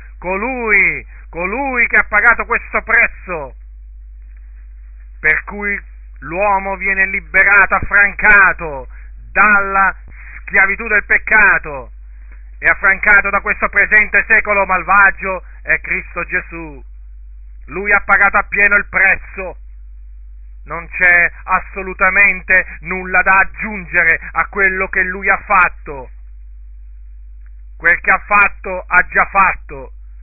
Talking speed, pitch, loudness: 105 wpm, 185 Hz, -12 LUFS